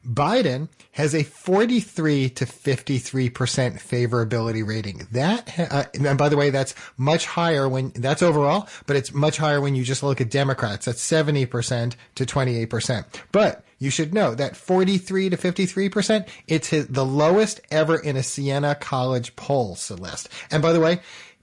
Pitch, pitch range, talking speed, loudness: 140 Hz, 130-160 Hz, 155 wpm, -22 LUFS